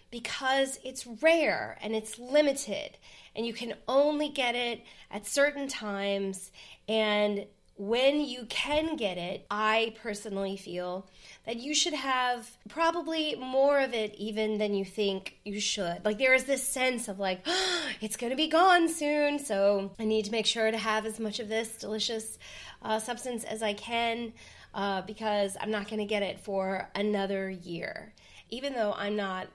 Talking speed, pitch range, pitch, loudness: 175 wpm, 205-260 Hz, 220 Hz, -30 LUFS